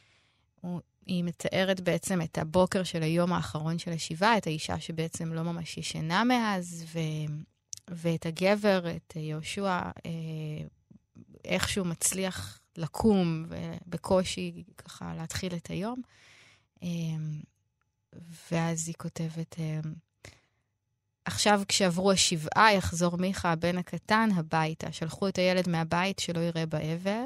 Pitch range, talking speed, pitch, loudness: 155-185 Hz, 105 wpm, 165 Hz, -30 LUFS